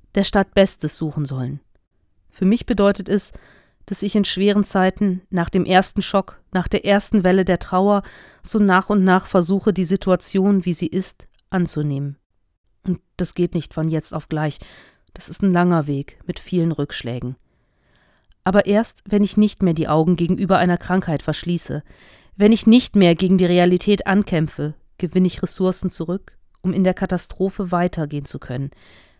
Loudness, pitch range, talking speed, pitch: -19 LUFS, 155-195 Hz, 170 wpm, 180 Hz